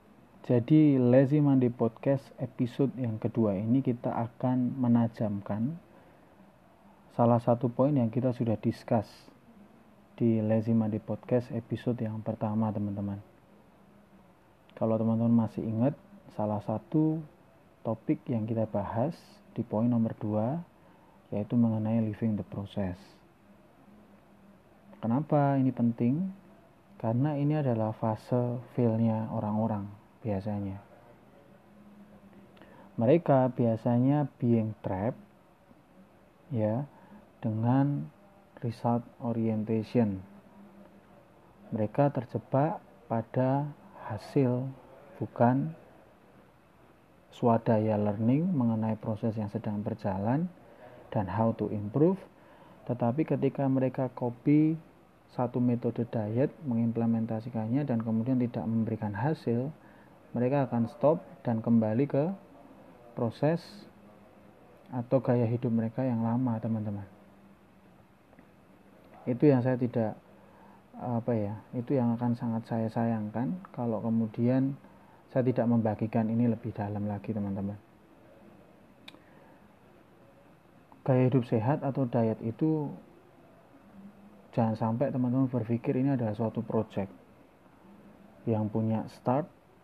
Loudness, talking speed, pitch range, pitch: -30 LUFS, 95 wpm, 110-130 Hz, 120 Hz